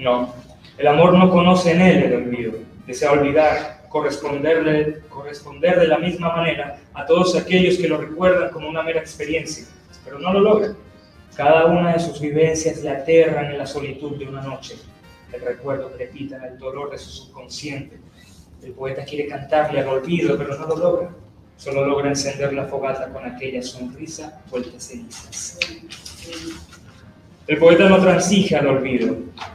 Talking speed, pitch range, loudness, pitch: 160 wpm, 135-165 Hz, -18 LUFS, 145 Hz